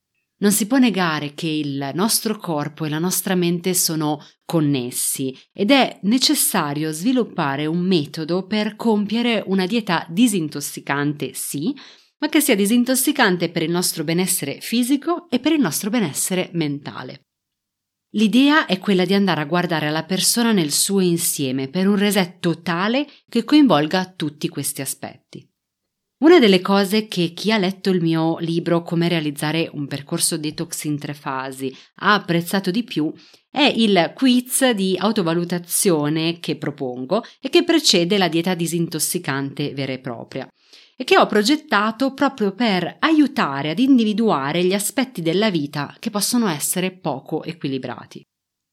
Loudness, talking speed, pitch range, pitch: -19 LUFS, 145 wpm, 155-220 Hz, 180 Hz